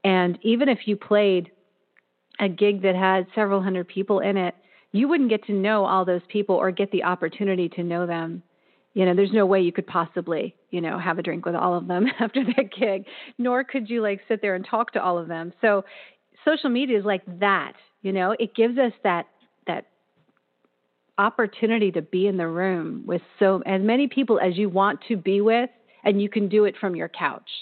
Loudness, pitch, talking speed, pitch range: -23 LUFS, 195 Hz, 215 wpm, 180-220 Hz